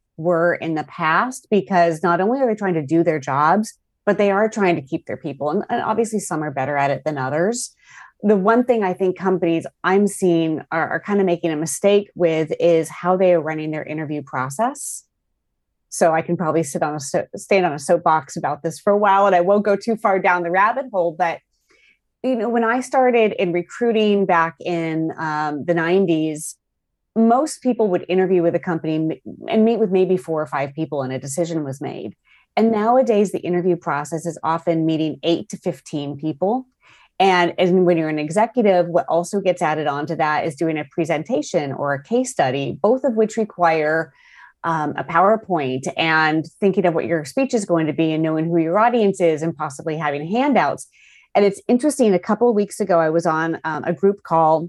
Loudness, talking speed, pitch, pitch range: -19 LUFS, 210 wpm, 175 Hz, 160-205 Hz